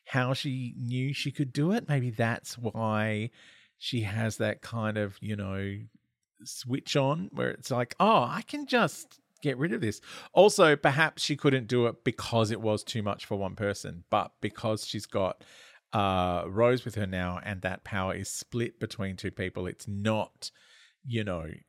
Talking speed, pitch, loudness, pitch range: 180 wpm, 110 Hz, -30 LUFS, 100-135 Hz